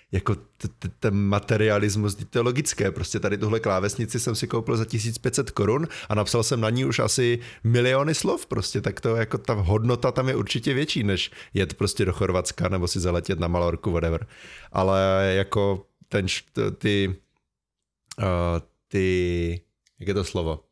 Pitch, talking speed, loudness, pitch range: 105 Hz, 170 wpm, -25 LUFS, 95-120 Hz